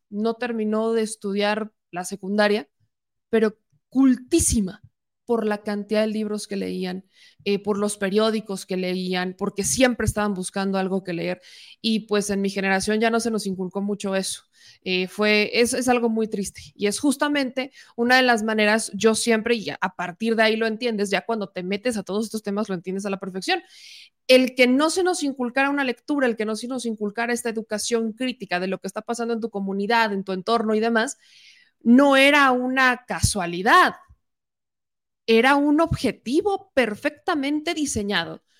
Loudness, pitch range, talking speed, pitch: -22 LUFS, 200-245 Hz, 180 wpm, 220 Hz